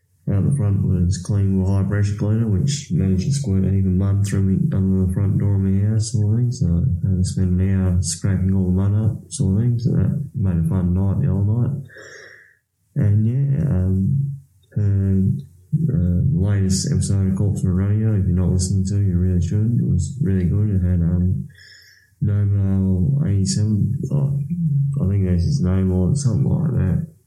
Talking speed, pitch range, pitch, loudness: 200 wpm, 95-120 Hz, 100 Hz, -20 LUFS